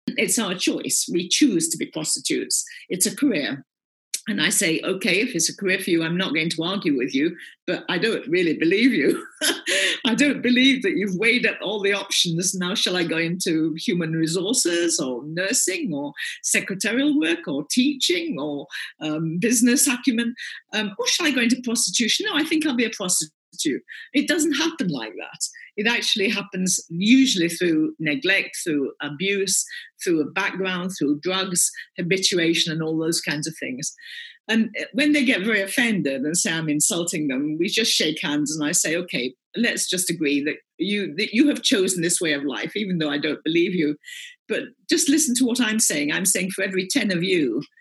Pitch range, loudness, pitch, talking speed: 165-270 Hz, -21 LUFS, 200 Hz, 195 wpm